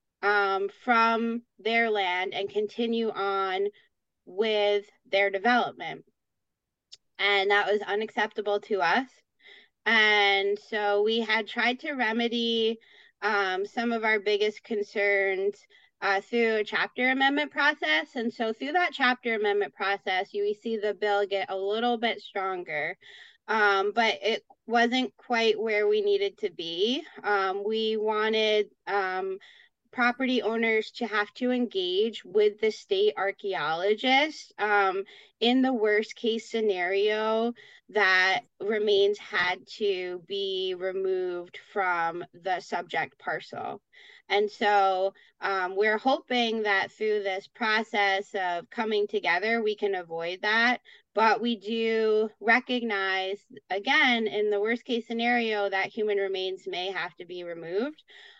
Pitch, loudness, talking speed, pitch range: 215 Hz, -27 LUFS, 130 wpm, 200-240 Hz